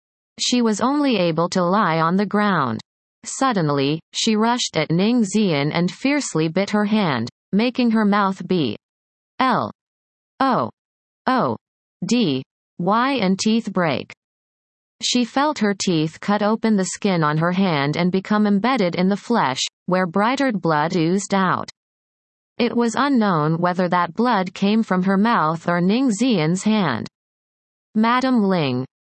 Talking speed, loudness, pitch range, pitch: 145 wpm, -20 LUFS, 170-225 Hz, 195 Hz